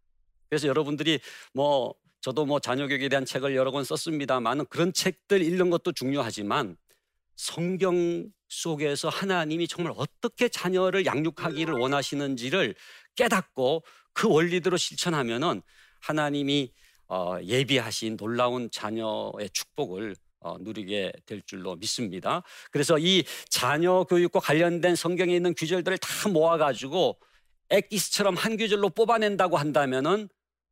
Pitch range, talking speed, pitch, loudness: 130-180 Hz, 310 characters per minute, 155 Hz, -27 LUFS